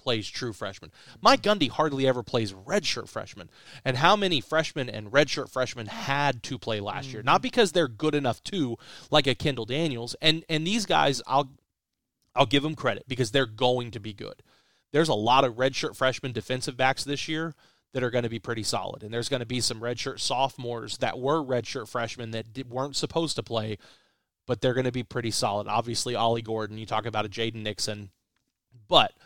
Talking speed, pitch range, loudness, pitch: 205 wpm, 115-140 Hz, -27 LUFS, 125 Hz